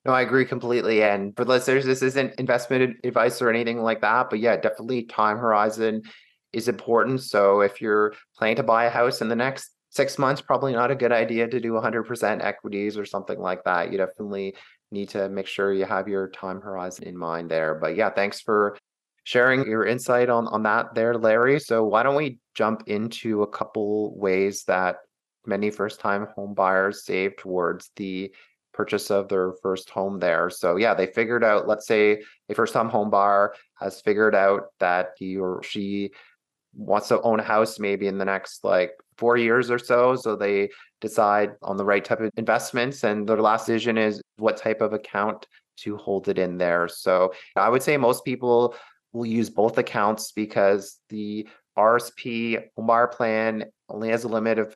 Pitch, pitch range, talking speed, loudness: 110 Hz, 100-115 Hz, 190 wpm, -23 LUFS